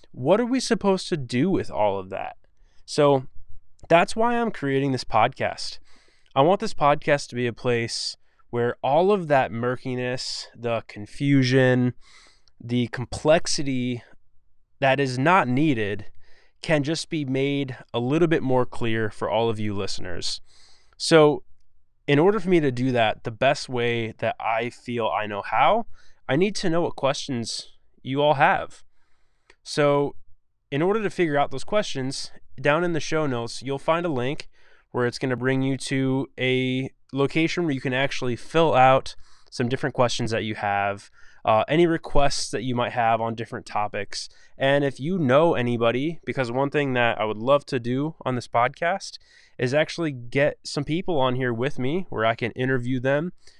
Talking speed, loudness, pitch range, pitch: 175 wpm, -24 LUFS, 120-150 Hz, 130 Hz